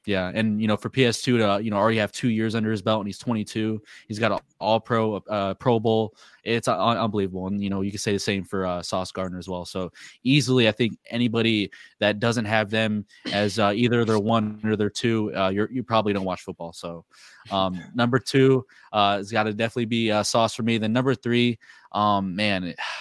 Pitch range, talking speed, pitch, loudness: 100-115 Hz, 230 wpm, 110 Hz, -24 LUFS